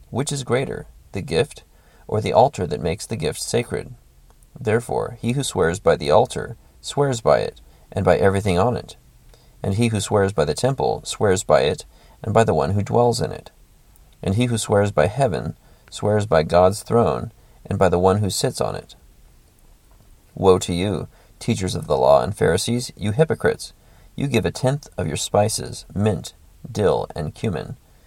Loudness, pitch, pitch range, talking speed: -21 LUFS, 105 Hz, 95-120 Hz, 185 wpm